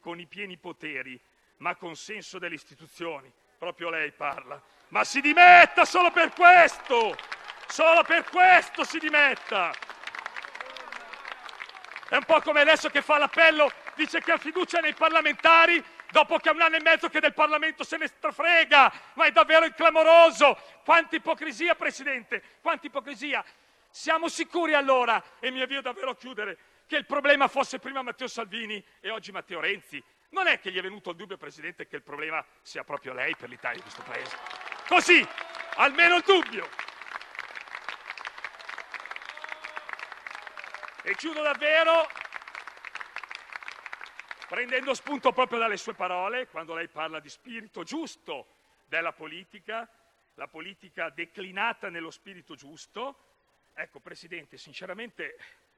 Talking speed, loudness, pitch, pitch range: 140 wpm, -22 LUFS, 285 Hz, 205-325 Hz